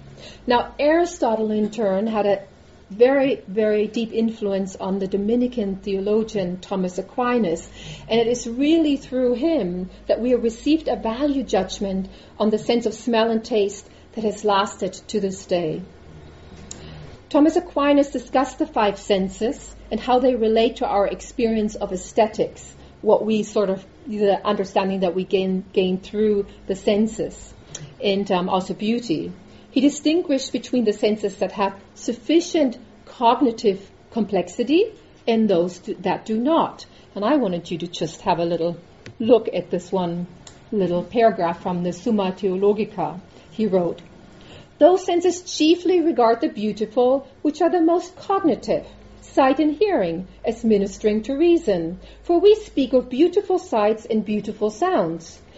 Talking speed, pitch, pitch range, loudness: 150 wpm, 215 Hz, 190-260 Hz, -21 LUFS